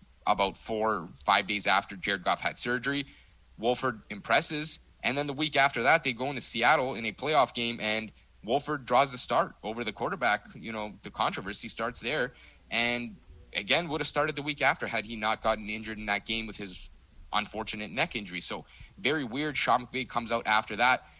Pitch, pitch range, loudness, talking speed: 115 Hz, 105-135 Hz, -29 LUFS, 200 wpm